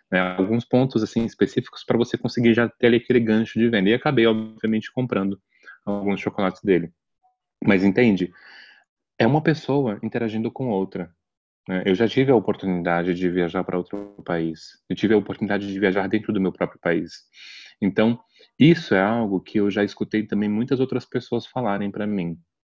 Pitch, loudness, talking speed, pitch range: 105 Hz, -22 LUFS, 175 wpm, 95-120 Hz